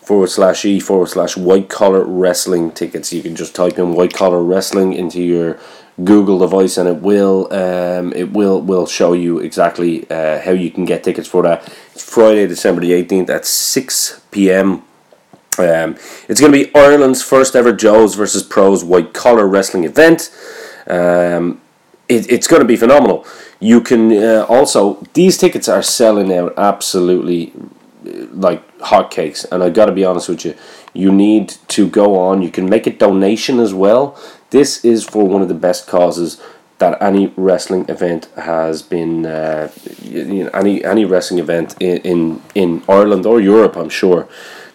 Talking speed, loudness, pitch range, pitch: 175 wpm, -12 LUFS, 90-100 Hz, 95 Hz